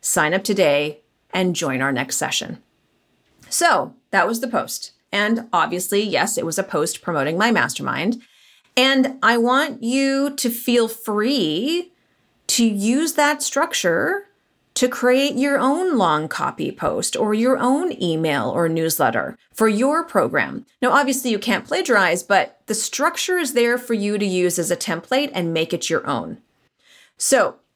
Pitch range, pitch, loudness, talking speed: 195-275 Hz, 240 Hz, -20 LUFS, 160 wpm